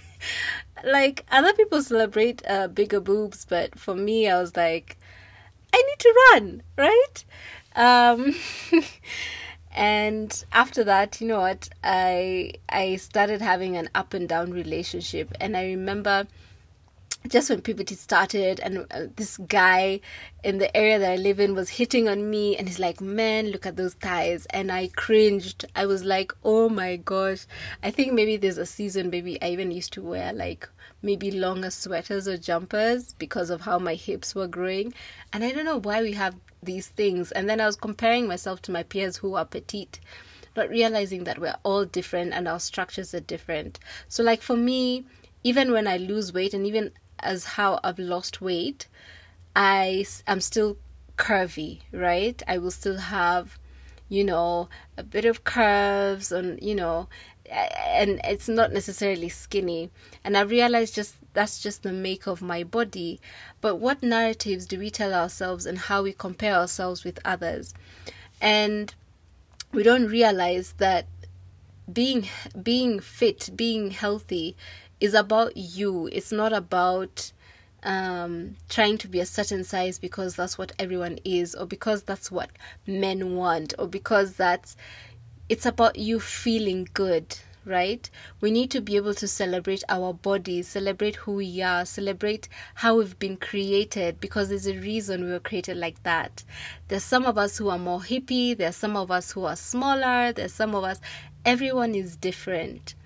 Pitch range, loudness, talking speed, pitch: 180-215 Hz, -25 LUFS, 165 wpm, 195 Hz